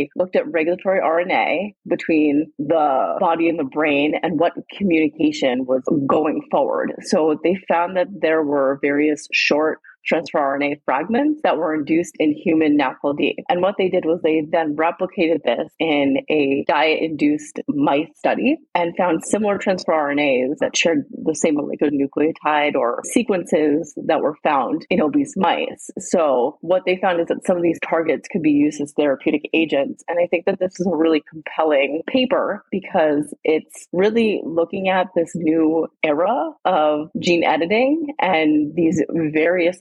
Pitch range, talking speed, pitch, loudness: 150-190 Hz, 160 wpm, 165 Hz, -19 LUFS